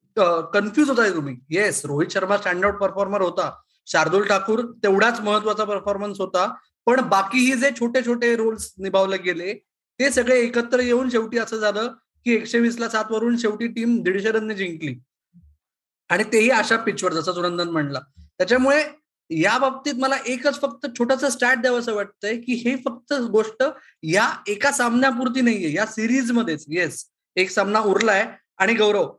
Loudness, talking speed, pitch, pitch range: -21 LUFS, 160 wpm, 220 Hz, 195-255 Hz